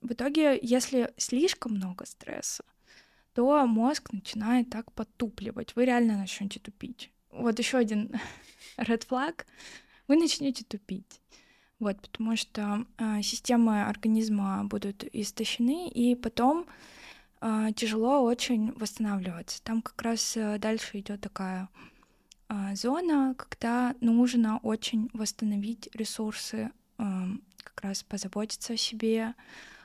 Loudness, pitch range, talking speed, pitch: -30 LUFS, 210-245 Hz, 115 wpm, 225 Hz